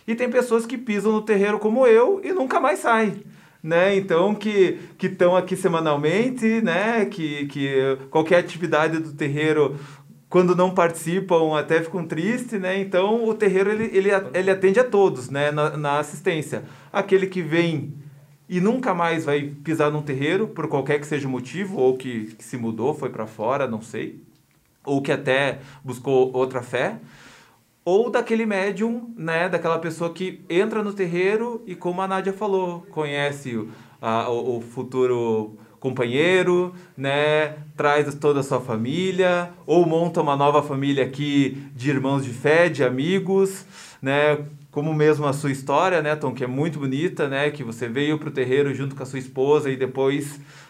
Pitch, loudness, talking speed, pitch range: 155 Hz, -22 LUFS, 170 wpm, 140-190 Hz